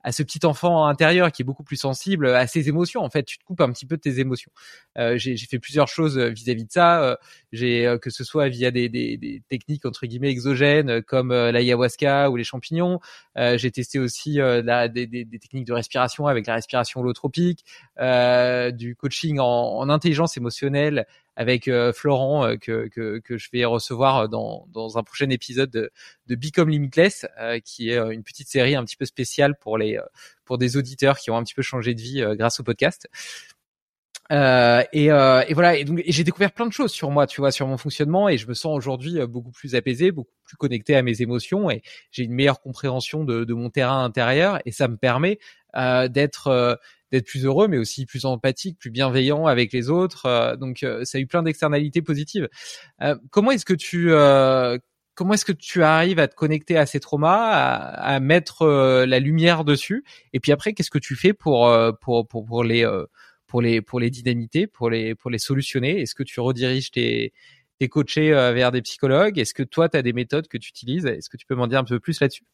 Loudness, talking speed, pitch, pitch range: -21 LUFS, 225 wpm, 135 Hz, 120-150 Hz